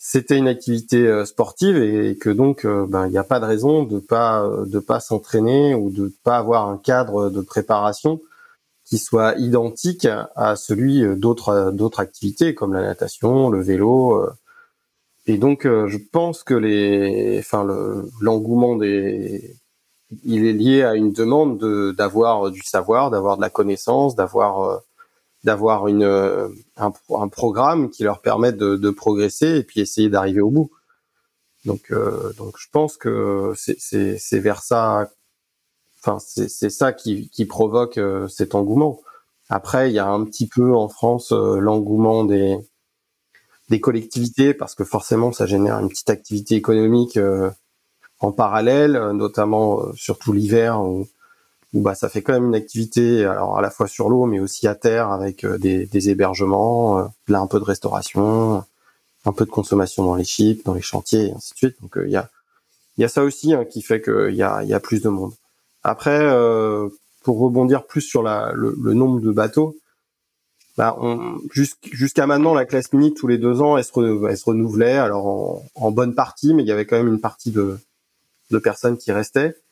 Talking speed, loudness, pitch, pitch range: 185 wpm, -19 LUFS, 110 Hz, 100-130 Hz